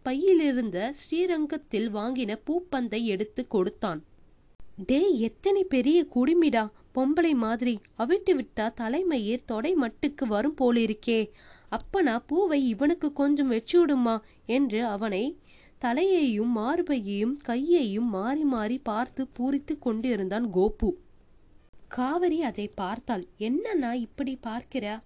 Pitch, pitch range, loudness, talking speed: 250 Hz, 220-295 Hz, -27 LUFS, 100 wpm